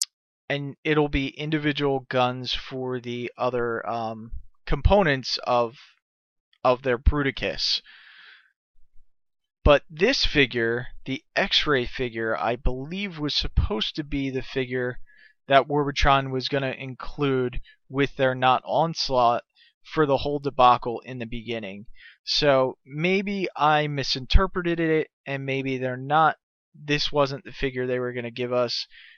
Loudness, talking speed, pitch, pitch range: -24 LUFS, 130 wpm, 130 Hz, 125-145 Hz